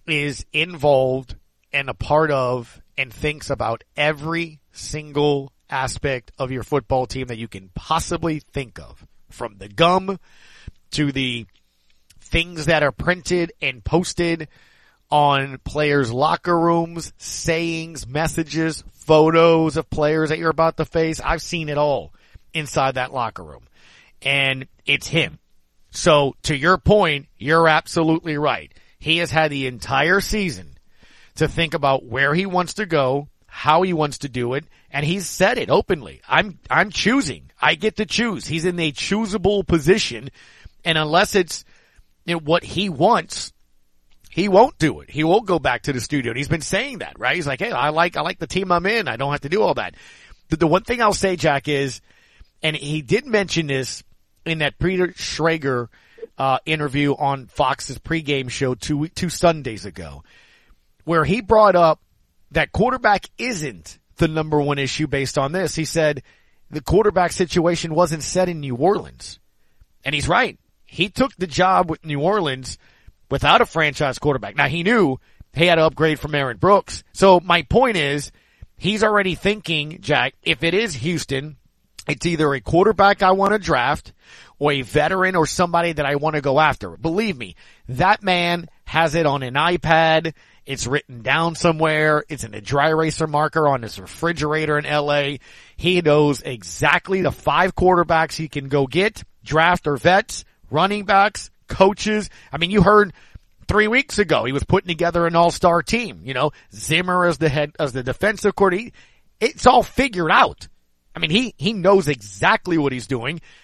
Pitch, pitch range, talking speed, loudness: 155 Hz, 140-175 Hz, 170 wpm, -19 LUFS